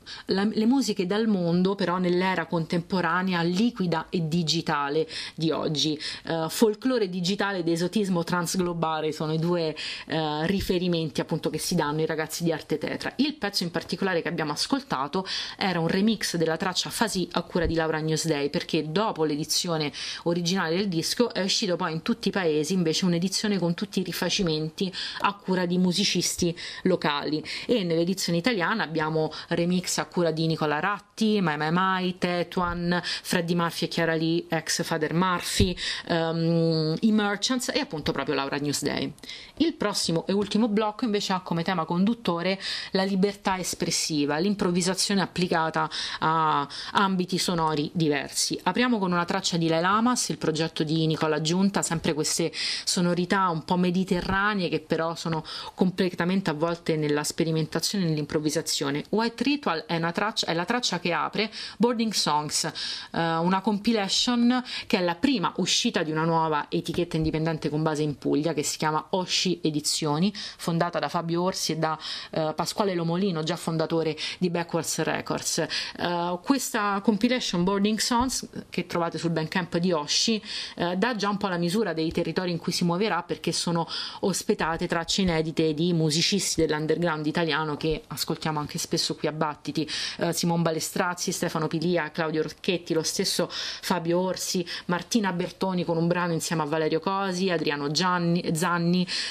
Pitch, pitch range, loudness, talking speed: 175 Hz, 160-195 Hz, -26 LUFS, 160 wpm